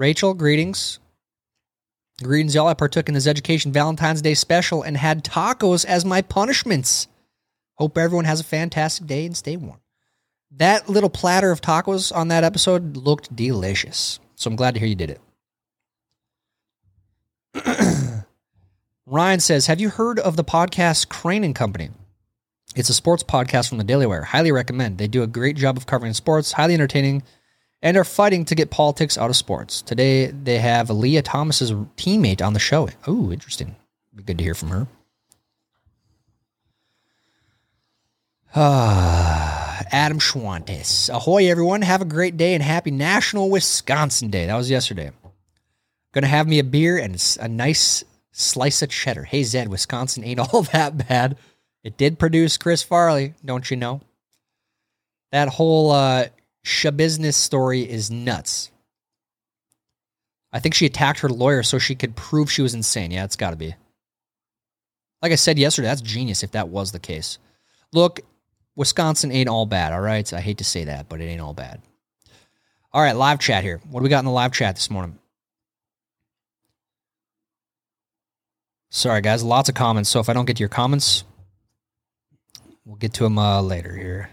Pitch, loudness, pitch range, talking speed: 130 Hz, -19 LUFS, 110-155 Hz, 165 wpm